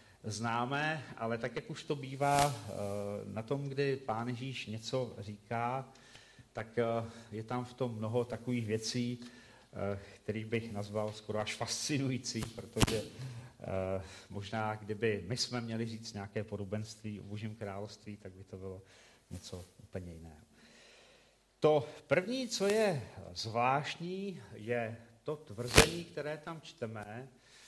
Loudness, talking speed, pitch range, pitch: -36 LUFS, 125 wpm, 105-130 Hz, 115 Hz